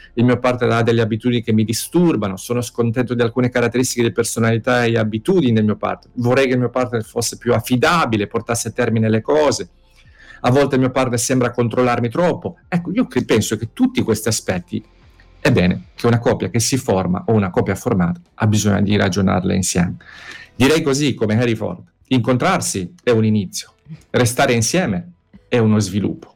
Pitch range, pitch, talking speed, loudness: 105-125 Hz, 115 Hz, 185 wpm, -18 LUFS